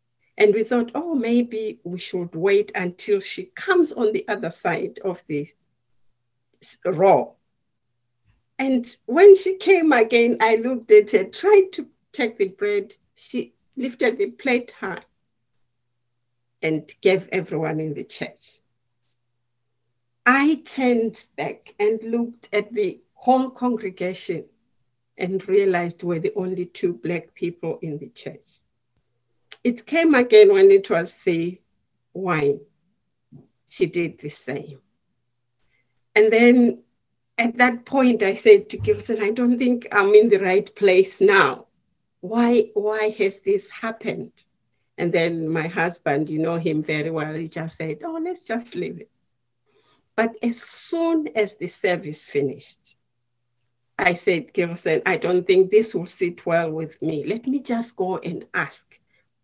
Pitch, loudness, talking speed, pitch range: 190 Hz, -21 LUFS, 140 wpm, 150-245 Hz